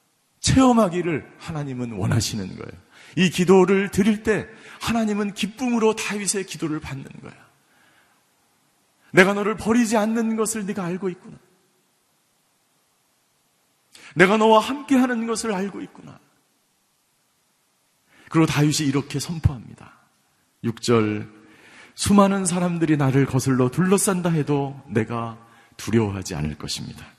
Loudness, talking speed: -21 LUFS, 265 characters per minute